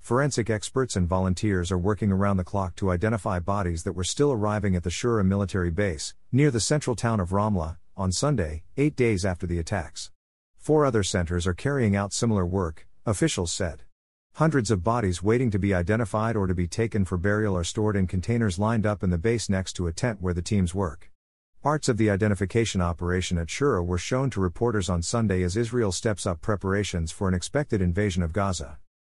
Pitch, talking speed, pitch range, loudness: 100 Hz, 205 wpm, 90-115 Hz, -26 LUFS